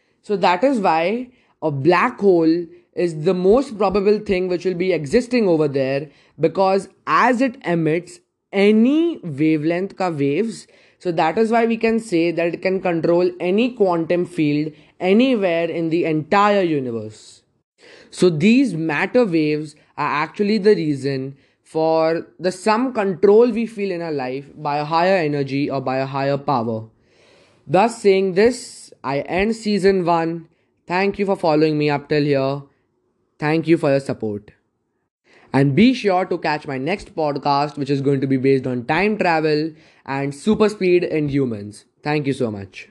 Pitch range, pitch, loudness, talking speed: 145-195 Hz, 170 Hz, -19 LUFS, 165 wpm